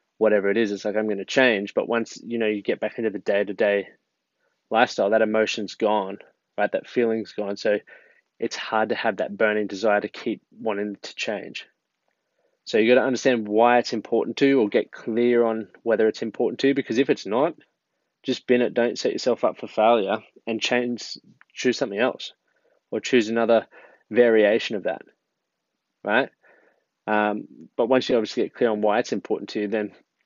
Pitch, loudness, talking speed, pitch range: 110 Hz, -23 LUFS, 195 wpm, 105-120 Hz